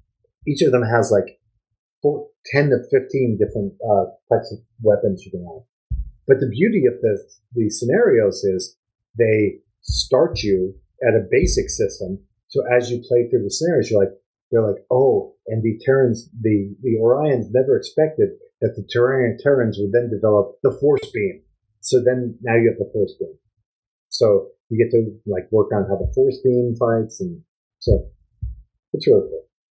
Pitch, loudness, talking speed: 125 Hz, -19 LUFS, 175 wpm